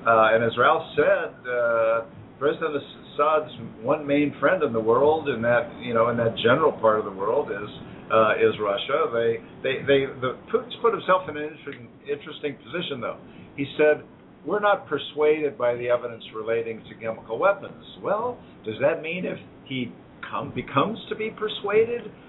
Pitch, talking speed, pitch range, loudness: 130 Hz, 175 wpm, 115-150 Hz, -24 LUFS